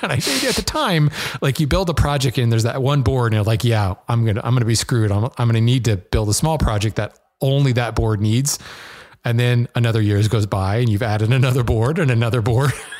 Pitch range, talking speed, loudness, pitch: 110-130 Hz, 255 wpm, -18 LUFS, 120 Hz